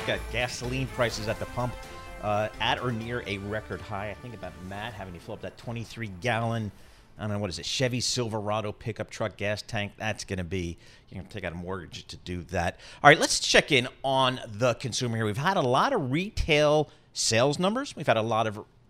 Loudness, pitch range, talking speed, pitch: -27 LUFS, 100-125 Hz, 230 wpm, 110 Hz